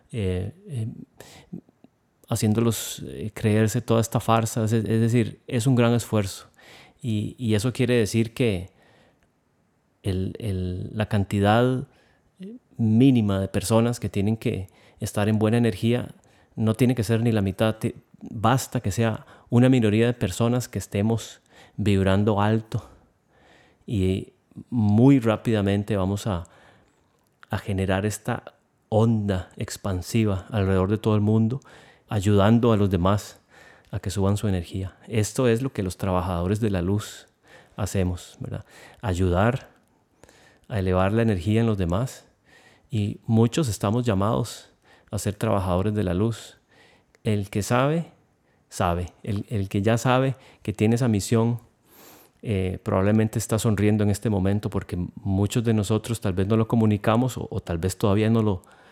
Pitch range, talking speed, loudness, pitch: 100-115 Hz, 145 wpm, -24 LUFS, 110 Hz